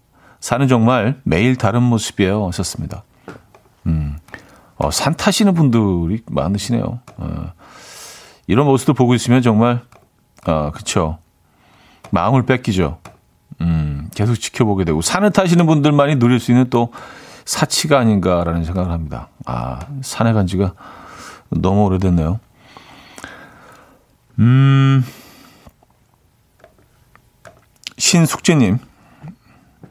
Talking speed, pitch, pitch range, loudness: 220 characters per minute, 115 Hz, 95-130 Hz, -16 LUFS